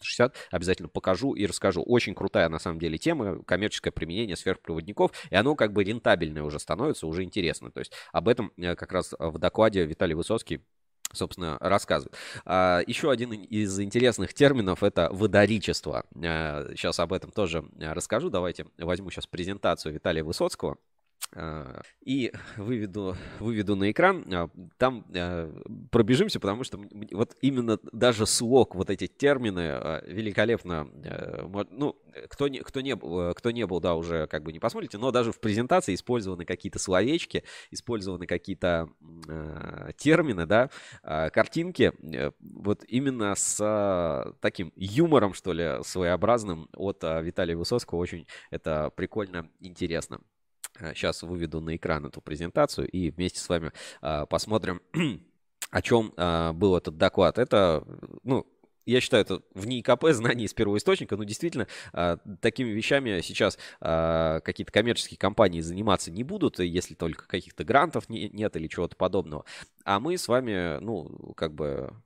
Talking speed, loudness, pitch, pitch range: 140 wpm, -28 LUFS, 95 Hz, 85-110 Hz